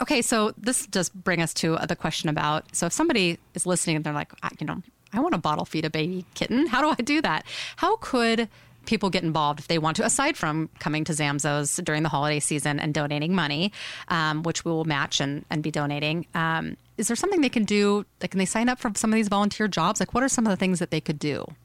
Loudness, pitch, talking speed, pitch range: -25 LUFS, 175 Hz, 260 wpm, 155-220 Hz